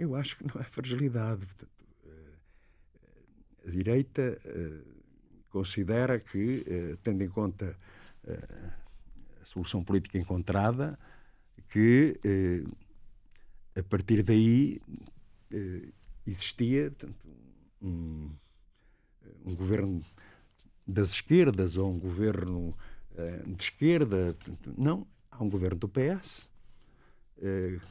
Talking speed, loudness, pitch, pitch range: 80 wpm, -30 LUFS, 100 Hz, 90-115 Hz